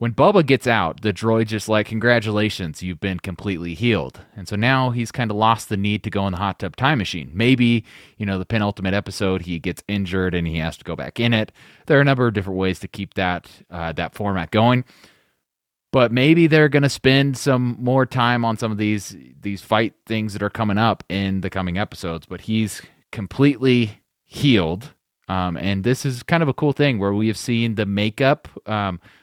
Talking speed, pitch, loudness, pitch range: 215 wpm, 105 Hz, -20 LUFS, 95-120 Hz